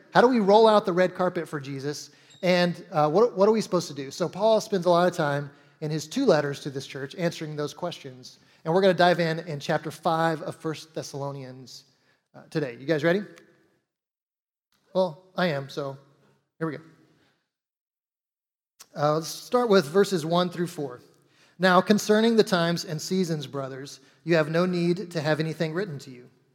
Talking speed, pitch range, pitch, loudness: 190 wpm, 145-180 Hz, 160 Hz, -25 LUFS